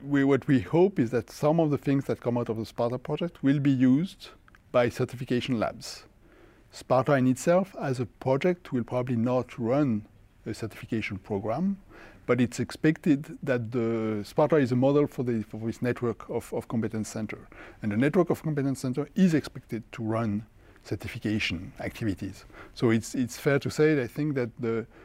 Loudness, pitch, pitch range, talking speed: -28 LUFS, 125 Hz, 110-140 Hz, 185 wpm